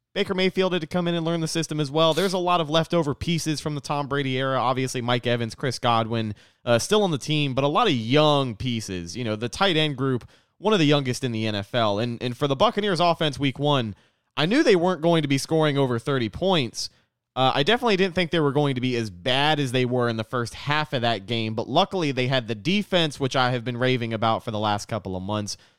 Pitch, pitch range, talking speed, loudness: 135 Hz, 120-160 Hz, 260 wpm, -23 LUFS